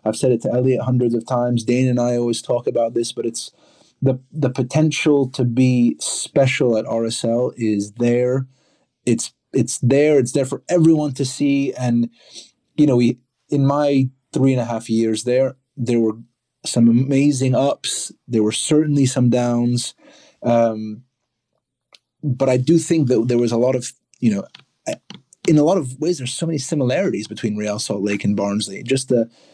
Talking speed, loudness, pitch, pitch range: 180 wpm, -19 LUFS, 125 Hz, 120-135 Hz